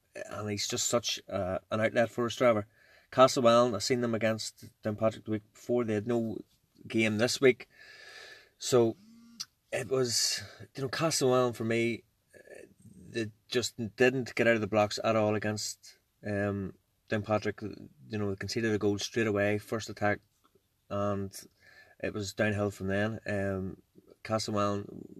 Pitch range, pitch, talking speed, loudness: 105-120 Hz, 110 Hz, 155 wpm, -30 LUFS